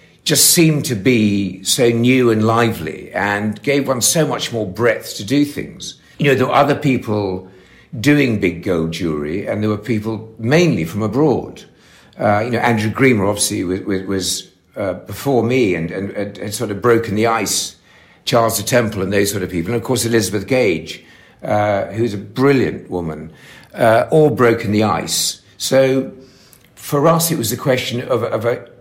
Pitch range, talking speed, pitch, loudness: 100-130 Hz, 185 wpm, 115 Hz, -16 LUFS